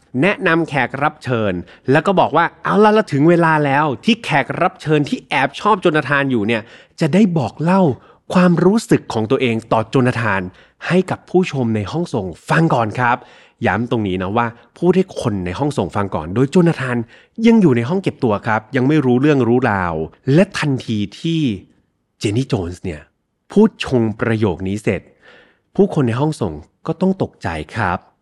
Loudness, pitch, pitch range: -17 LUFS, 130 Hz, 110-165 Hz